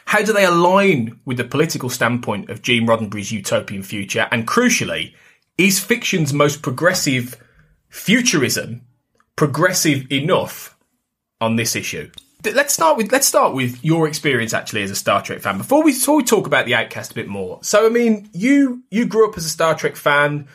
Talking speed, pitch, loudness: 175 wpm, 150 Hz, -17 LUFS